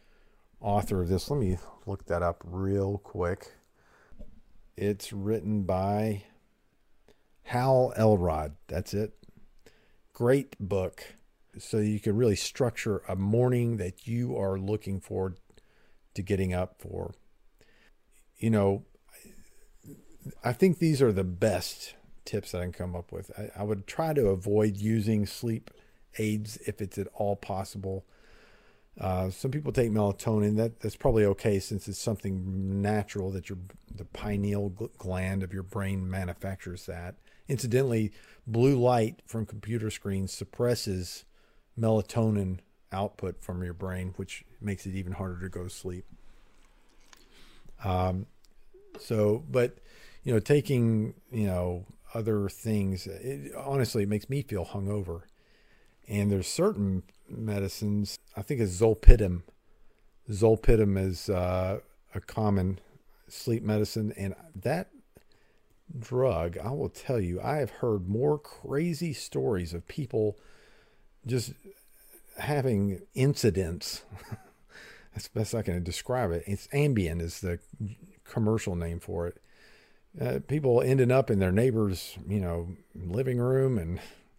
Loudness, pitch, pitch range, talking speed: -30 LUFS, 105 Hz, 95-115 Hz, 130 wpm